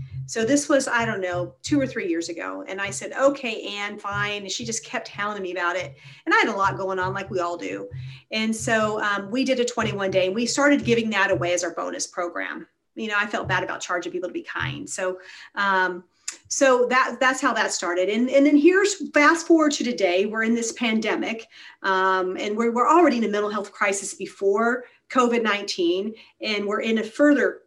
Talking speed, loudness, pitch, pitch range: 225 wpm, -23 LUFS, 210 Hz, 185-250 Hz